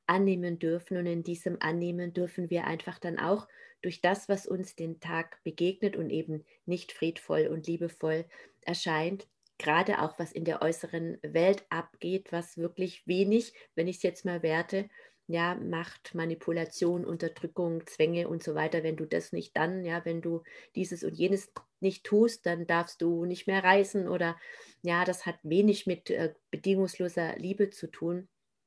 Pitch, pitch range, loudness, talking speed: 170 Hz, 165-185 Hz, -32 LUFS, 165 wpm